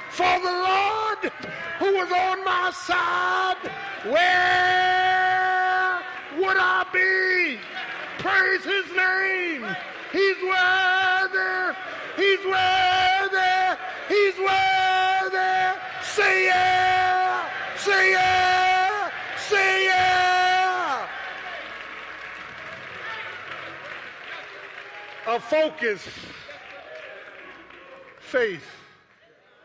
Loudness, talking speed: -21 LUFS, 65 wpm